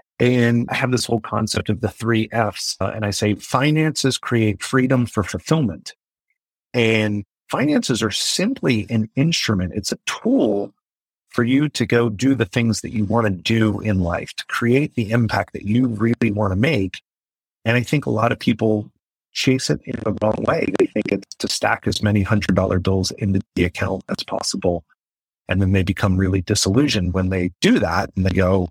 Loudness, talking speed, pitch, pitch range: -20 LUFS, 195 wpm, 110 Hz, 95-120 Hz